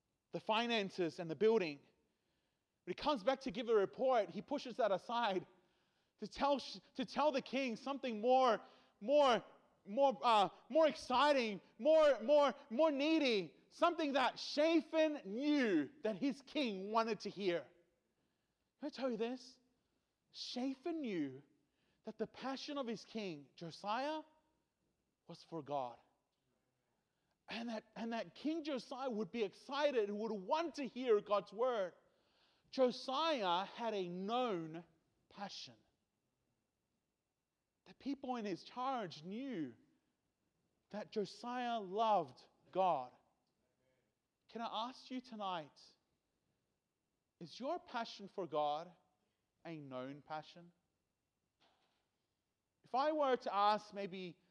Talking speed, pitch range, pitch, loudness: 120 wpm, 190-270 Hz, 225 Hz, -39 LUFS